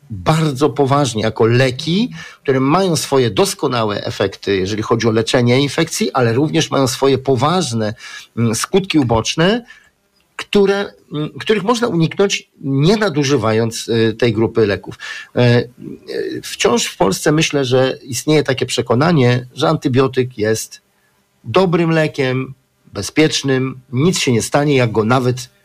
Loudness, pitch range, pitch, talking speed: -16 LUFS, 125-165 Hz, 140 Hz, 120 wpm